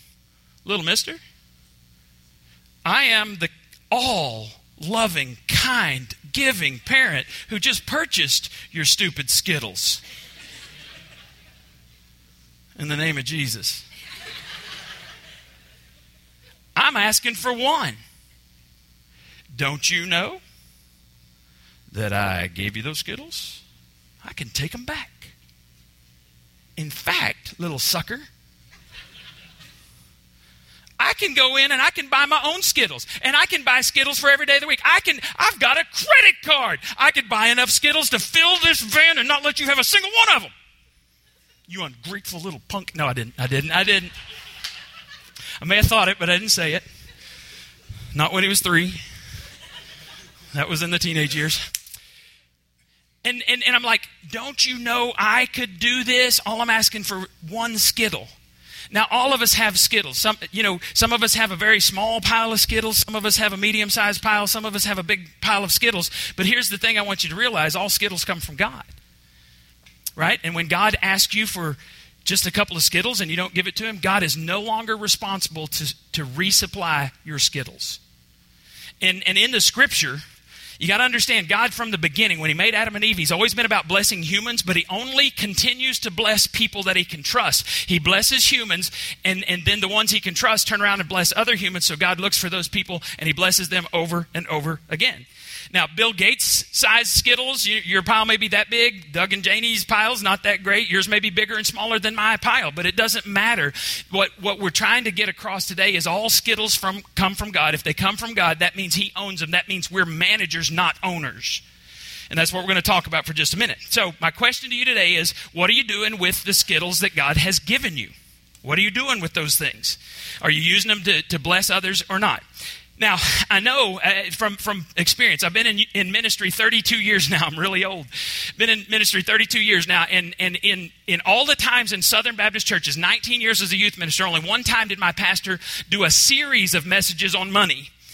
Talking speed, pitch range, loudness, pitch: 195 wpm, 155-220 Hz, -18 LUFS, 190 Hz